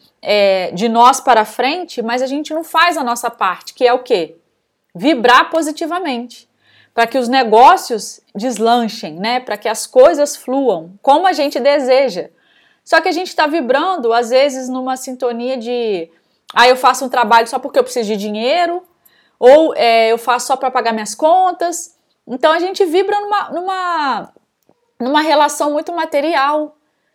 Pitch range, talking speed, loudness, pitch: 235-320 Hz, 165 wpm, -14 LUFS, 260 Hz